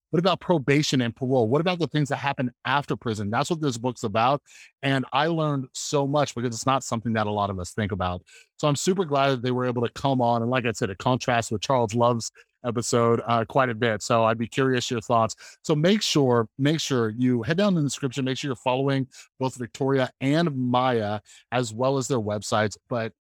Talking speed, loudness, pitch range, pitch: 230 wpm, -24 LUFS, 115-140 Hz, 125 Hz